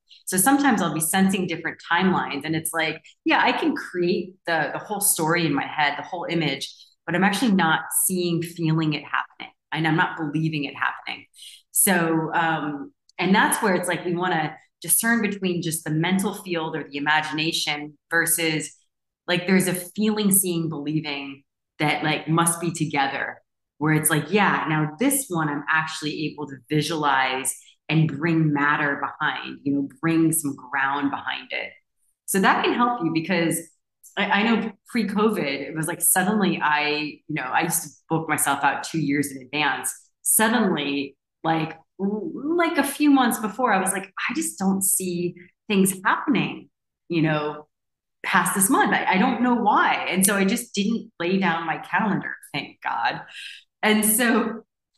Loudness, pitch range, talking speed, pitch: -22 LUFS, 150-195 Hz, 170 wpm, 165 Hz